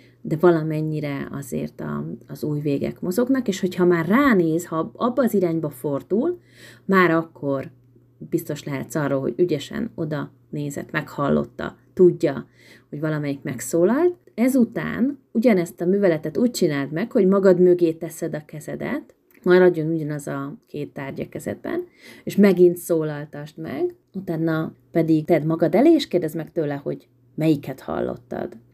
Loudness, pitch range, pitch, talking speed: -22 LUFS, 150-190 Hz, 165 Hz, 140 wpm